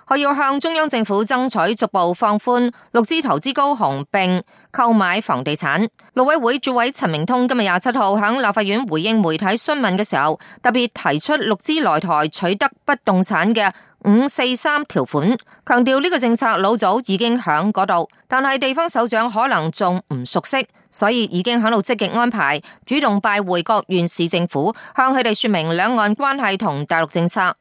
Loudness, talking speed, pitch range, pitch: -18 LUFS, 280 characters per minute, 185-255 Hz, 225 Hz